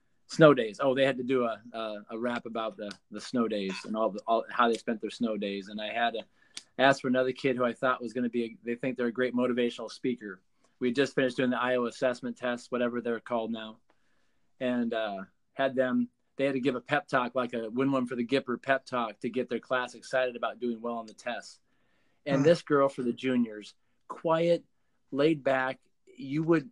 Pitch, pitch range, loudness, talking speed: 125 Hz, 115-135 Hz, -30 LUFS, 235 wpm